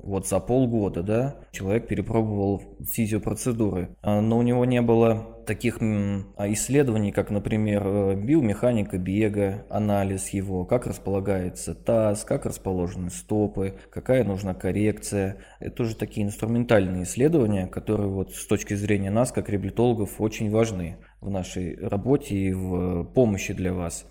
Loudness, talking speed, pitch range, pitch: -25 LUFS, 130 wpm, 95-115 Hz, 100 Hz